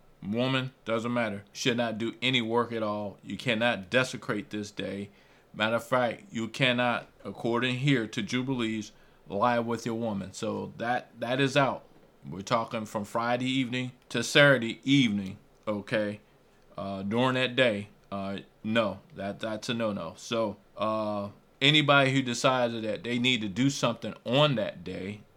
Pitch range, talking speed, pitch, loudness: 105-130 Hz, 160 wpm, 115 Hz, -28 LUFS